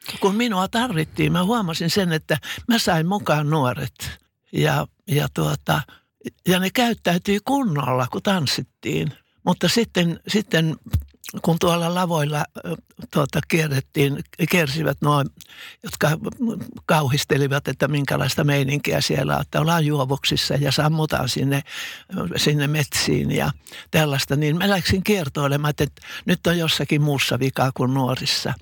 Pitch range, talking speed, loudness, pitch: 140-180 Hz, 120 wpm, -21 LUFS, 155 Hz